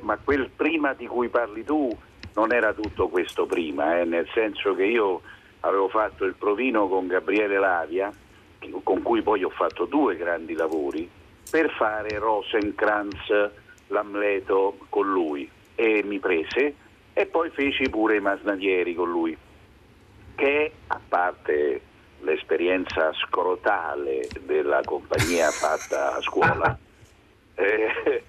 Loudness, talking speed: -24 LUFS, 125 wpm